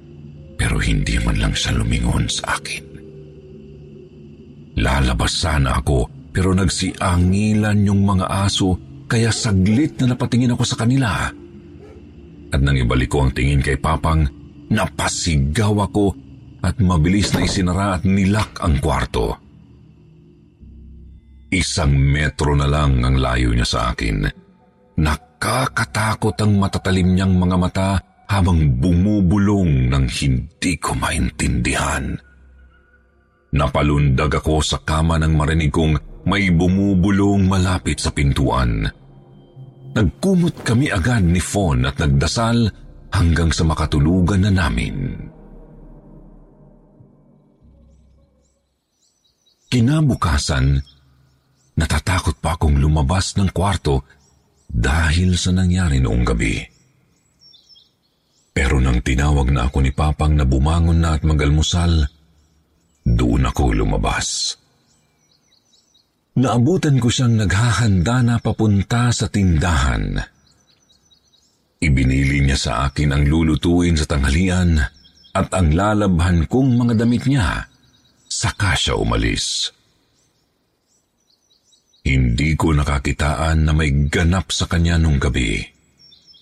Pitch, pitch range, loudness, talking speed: 80 Hz, 70-95 Hz, -18 LUFS, 105 wpm